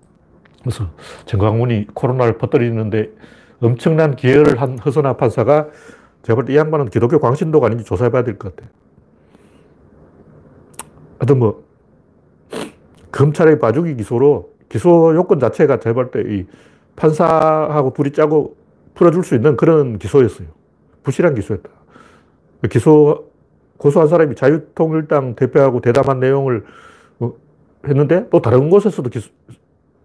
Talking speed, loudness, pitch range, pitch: 280 characters per minute, -15 LUFS, 115-155 Hz, 135 Hz